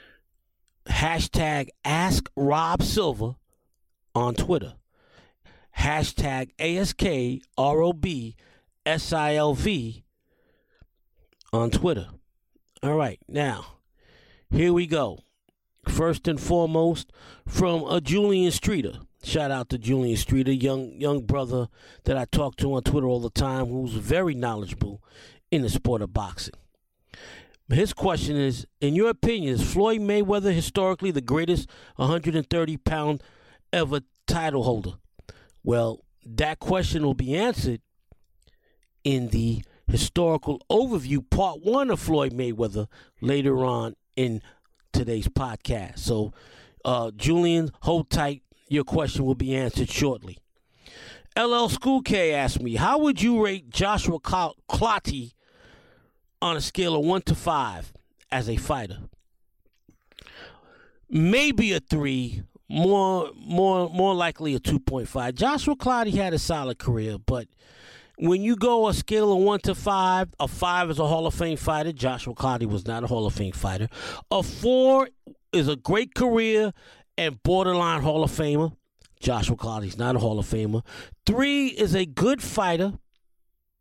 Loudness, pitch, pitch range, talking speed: -25 LUFS, 145 Hz, 120-175 Hz, 130 wpm